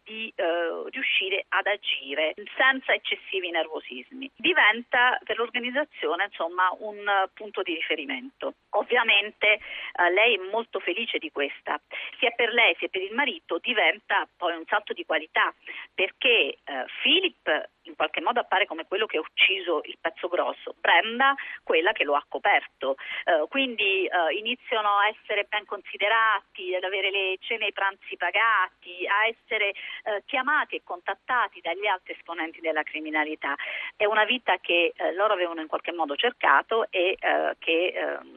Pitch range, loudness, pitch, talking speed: 185-260 Hz, -25 LUFS, 210 Hz, 160 wpm